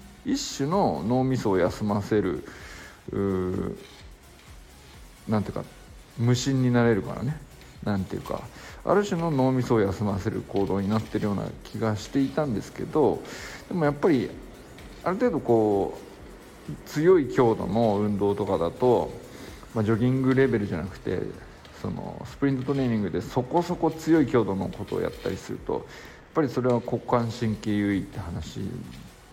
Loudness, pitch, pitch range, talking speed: -26 LUFS, 115 Hz, 105-135 Hz, 315 characters per minute